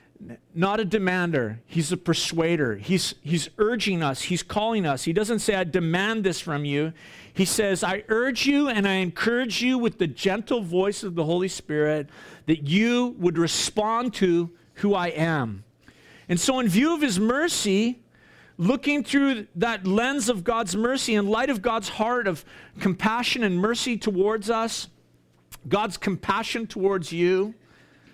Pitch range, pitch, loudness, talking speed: 170-230 Hz, 195 Hz, -24 LUFS, 160 wpm